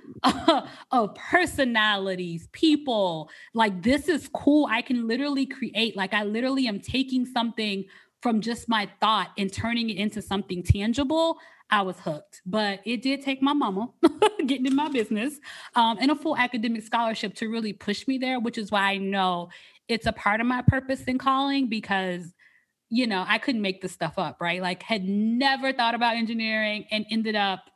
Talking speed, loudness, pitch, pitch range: 180 wpm, -25 LUFS, 225 Hz, 200-265 Hz